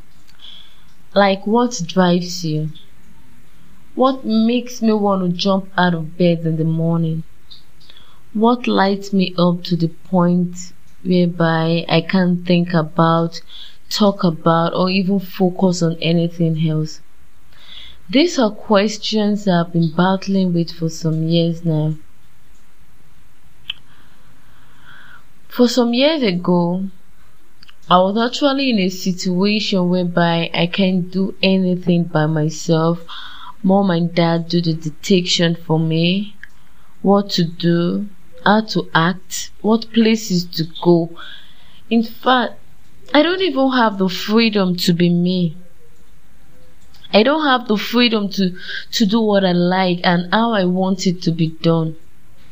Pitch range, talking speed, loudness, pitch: 170-200 Hz, 130 wpm, -17 LUFS, 180 Hz